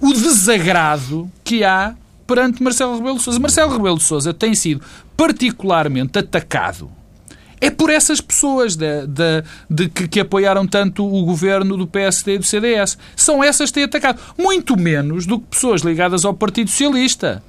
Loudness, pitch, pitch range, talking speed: -15 LUFS, 200 Hz, 180-255 Hz, 170 wpm